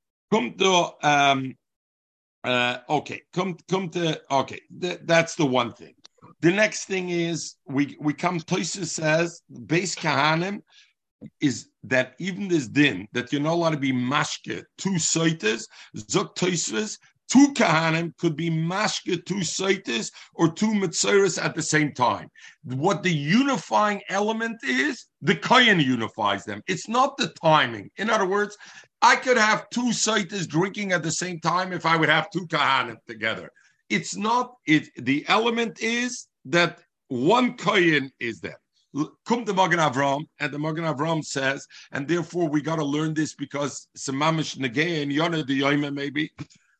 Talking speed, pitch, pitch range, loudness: 145 wpm, 165 Hz, 145-190 Hz, -23 LUFS